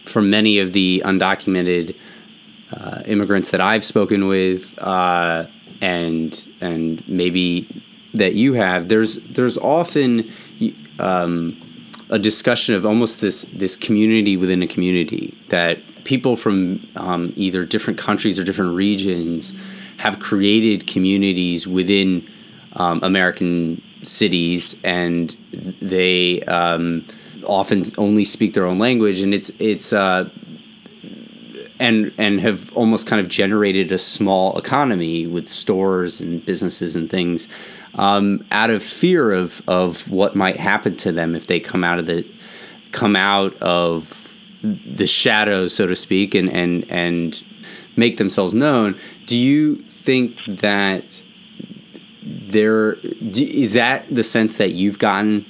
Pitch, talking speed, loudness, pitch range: 95 Hz, 130 wpm, -18 LUFS, 90-110 Hz